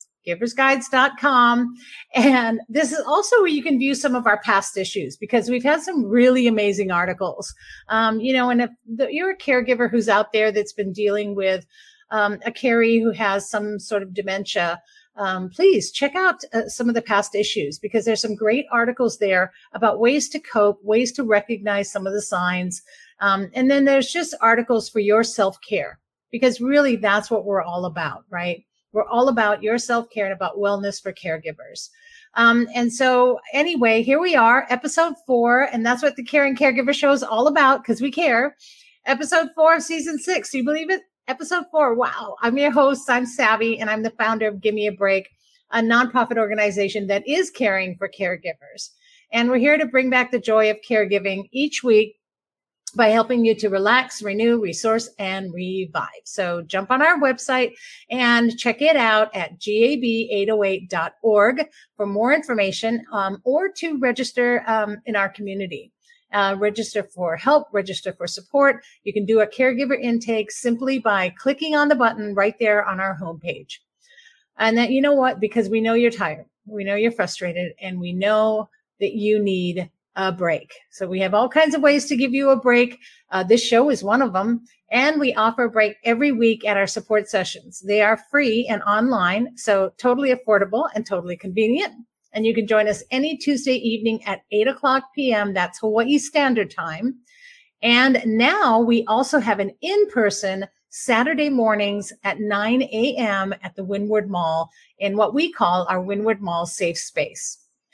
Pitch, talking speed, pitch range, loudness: 225 Hz, 180 wpm, 205-265 Hz, -20 LUFS